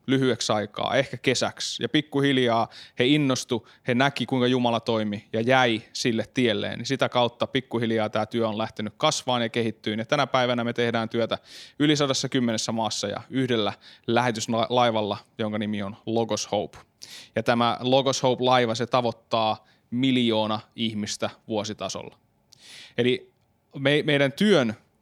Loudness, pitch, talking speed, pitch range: -25 LUFS, 120 Hz, 135 wpm, 110-130 Hz